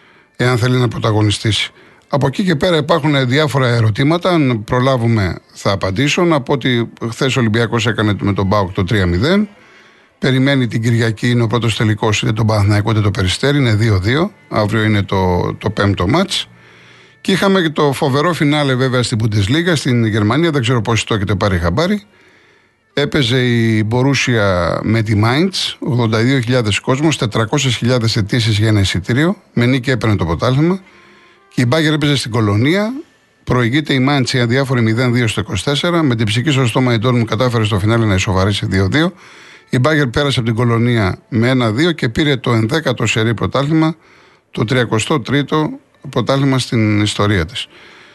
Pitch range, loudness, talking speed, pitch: 110-145 Hz, -15 LUFS, 160 wpm, 125 Hz